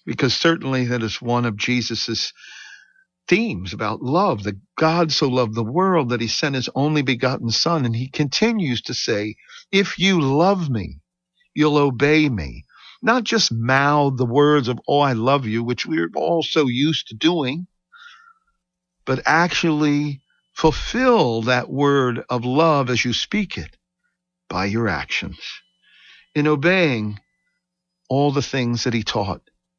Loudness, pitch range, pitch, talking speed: -20 LUFS, 120-175 Hz, 140 Hz, 150 wpm